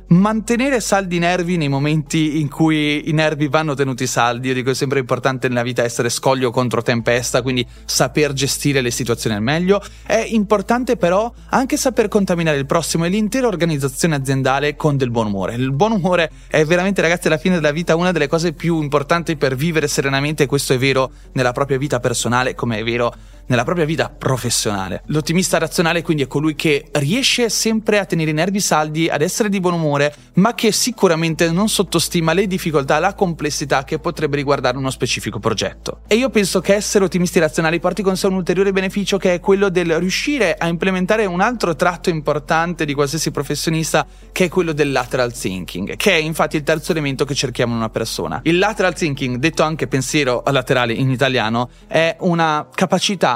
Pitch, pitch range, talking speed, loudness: 155 Hz, 135-185 Hz, 190 wpm, -17 LUFS